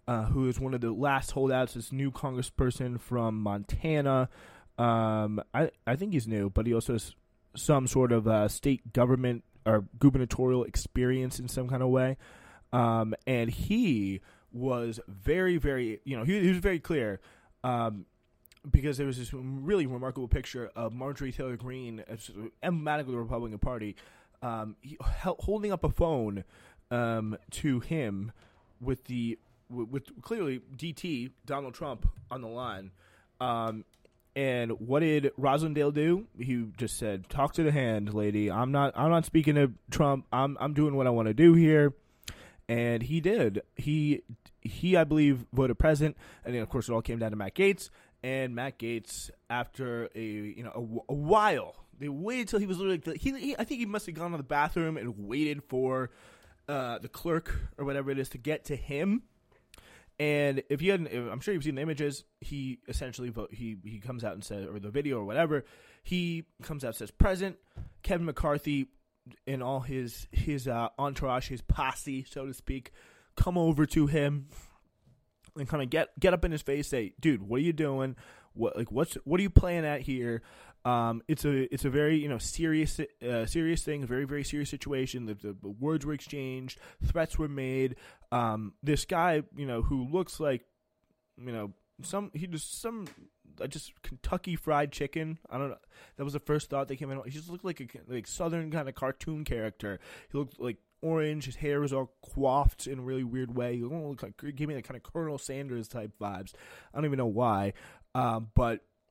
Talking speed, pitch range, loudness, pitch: 190 wpm, 115-150 Hz, -31 LUFS, 130 Hz